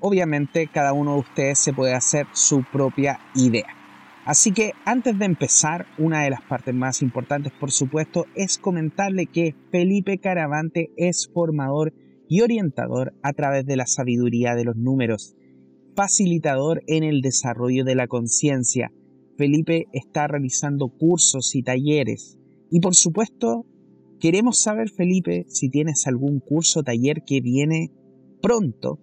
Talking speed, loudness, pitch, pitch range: 140 wpm, -21 LUFS, 145 Hz, 125-165 Hz